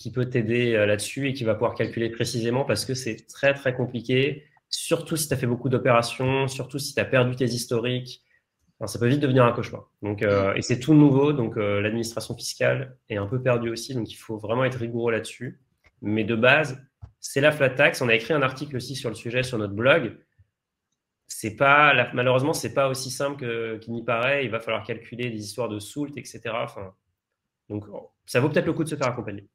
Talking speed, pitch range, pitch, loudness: 225 wpm, 115-135 Hz, 125 Hz, -24 LUFS